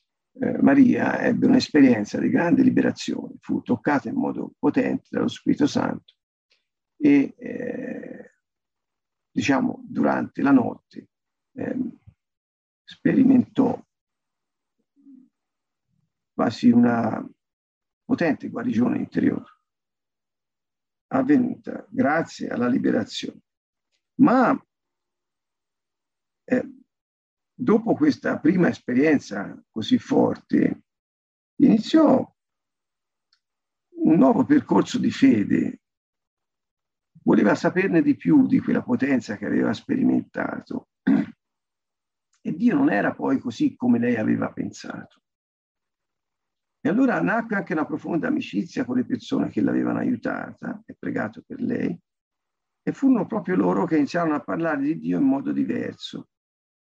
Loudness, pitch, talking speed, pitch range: -22 LUFS, 255 Hz, 100 wpm, 245-270 Hz